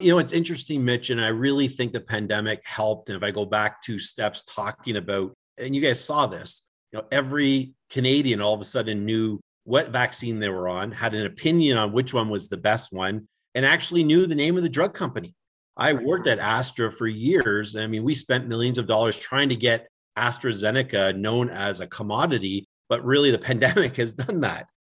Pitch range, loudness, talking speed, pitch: 105-135 Hz, -23 LUFS, 210 wpm, 115 Hz